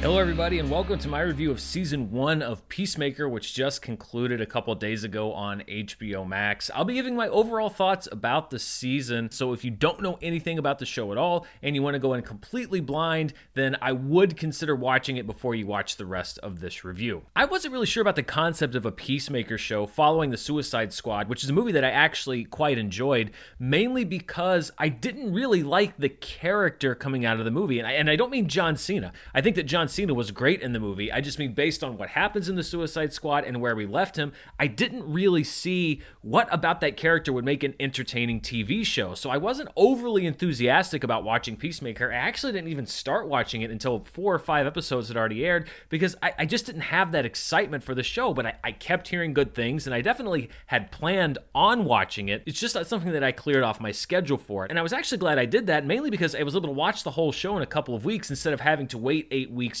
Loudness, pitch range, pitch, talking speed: -26 LUFS, 120-175 Hz, 145 Hz, 240 wpm